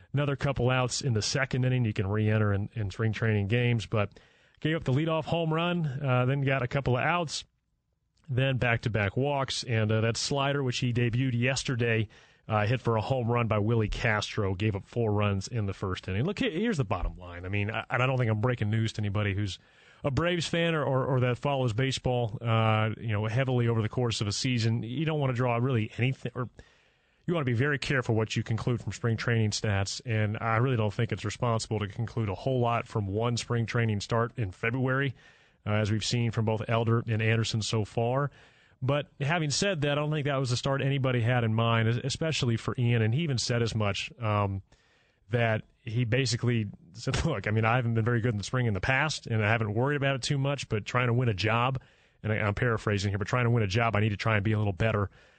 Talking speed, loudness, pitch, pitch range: 240 wpm, -29 LUFS, 120 Hz, 110-130 Hz